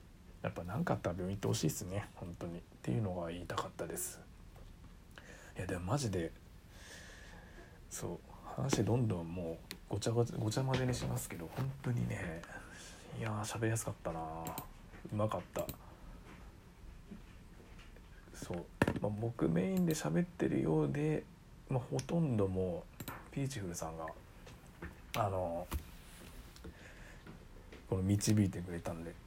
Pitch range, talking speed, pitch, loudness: 85-120 Hz, 270 characters per minute, 95 Hz, -38 LUFS